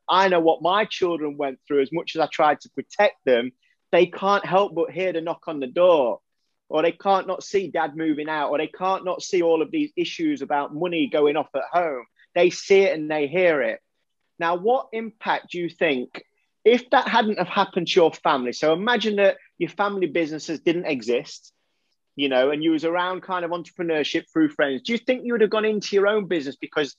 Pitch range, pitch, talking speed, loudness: 155-195 Hz, 175 Hz, 220 wpm, -22 LUFS